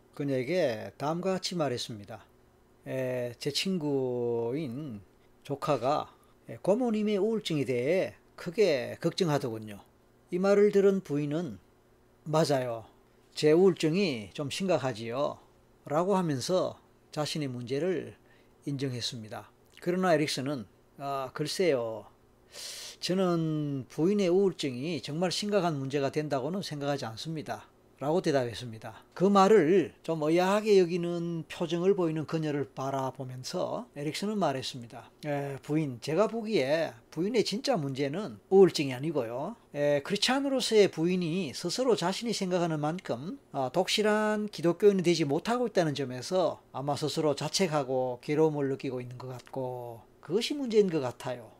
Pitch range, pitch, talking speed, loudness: 130-185 Hz, 150 Hz, 300 characters per minute, -29 LUFS